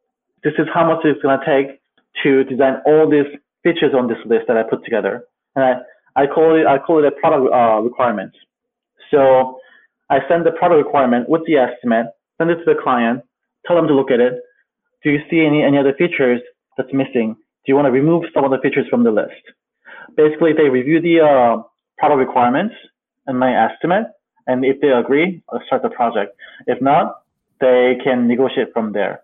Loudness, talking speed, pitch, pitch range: -16 LUFS, 200 wpm, 140 Hz, 130-160 Hz